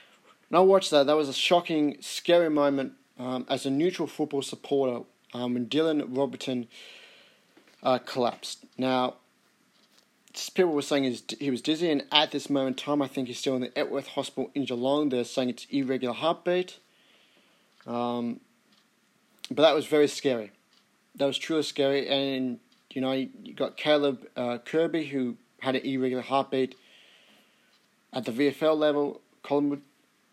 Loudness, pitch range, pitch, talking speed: -27 LUFS, 130-150 Hz, 140 Hz, 150 wpm